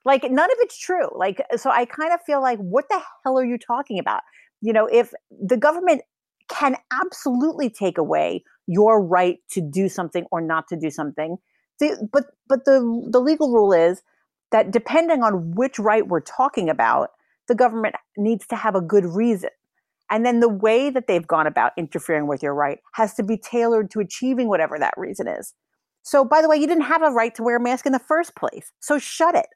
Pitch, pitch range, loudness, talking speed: 235 Hz, 195-280 Hz, -21 LUFS, 210 wpm